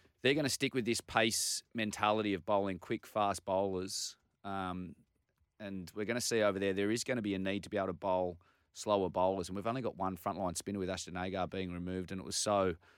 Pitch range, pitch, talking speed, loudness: 90-105 Hz, 95 Hz, 235 wpm, -35 LUFS